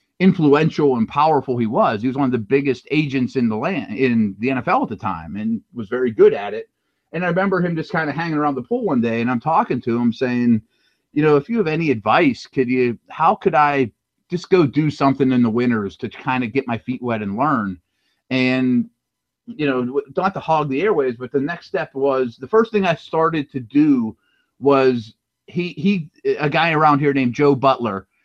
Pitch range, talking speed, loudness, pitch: 125-175 Hz, 220 wpm, -19 LUFS, 140 Hz